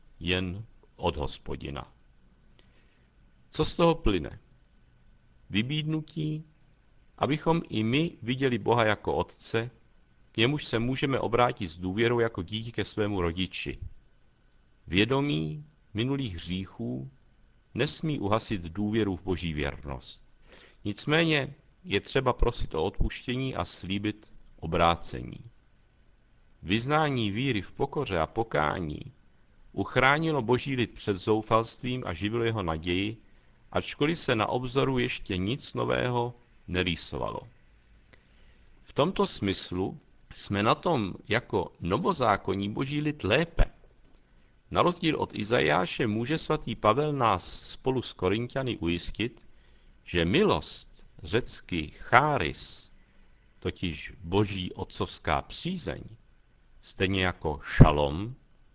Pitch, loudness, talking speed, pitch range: 110 Hz, -29 LUFS, 105 wpm, 90-130 Hz